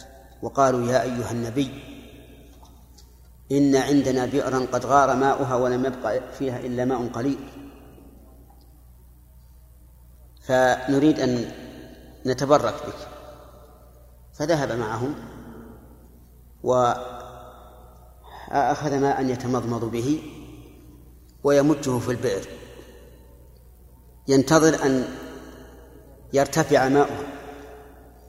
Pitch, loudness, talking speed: 125 Hz, -23 LUFS, 70 wpm